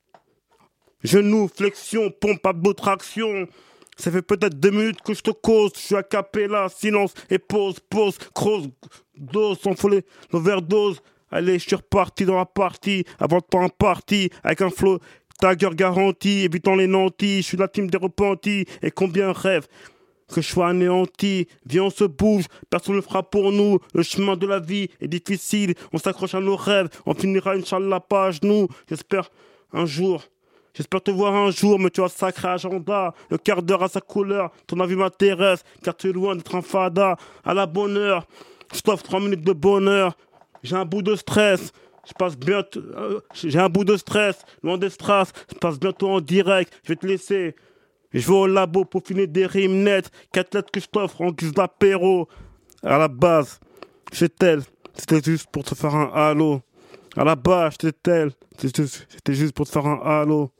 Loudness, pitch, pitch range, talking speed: -21 LUFS, 190 Hz, 175-200 Hz, 190 wpm